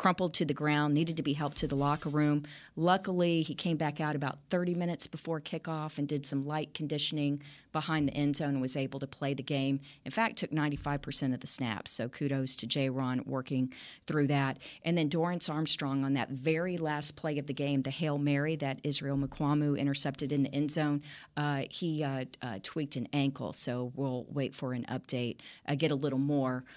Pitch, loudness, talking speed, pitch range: 145 Hz, -32 LUFS, 215 wpm, 135-155 Hz